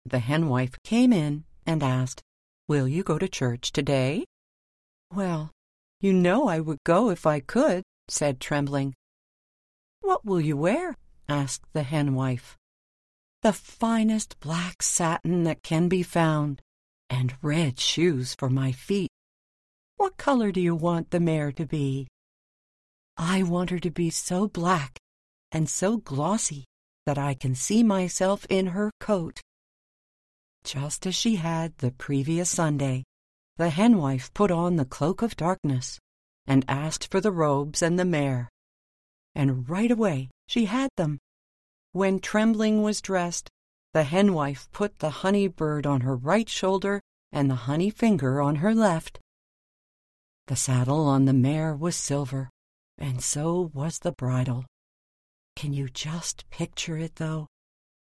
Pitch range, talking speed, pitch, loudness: 135-185 Hz, 145 wpm, 155 Hz, -26 LUFS